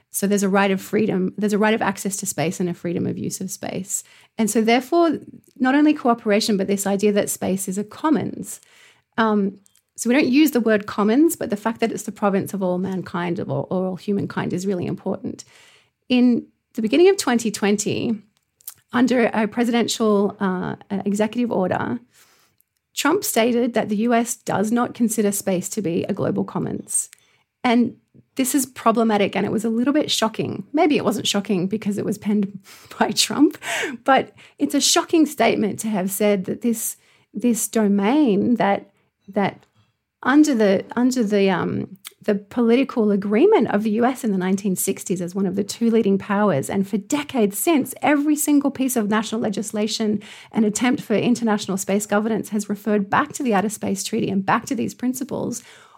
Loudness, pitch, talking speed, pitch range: -21 LUFS, 215 Hz, 180 wpm, 200-240 Hz